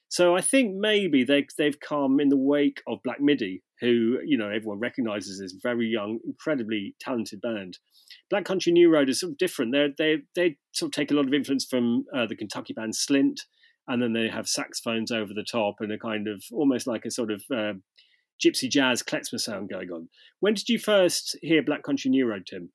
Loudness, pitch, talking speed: -26 LUFS, 140 Hz, 215 wpm